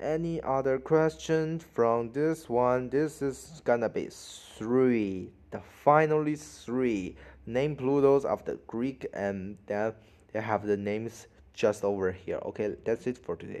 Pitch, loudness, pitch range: 125 Hz, -29 LUFS, 105-145 Hz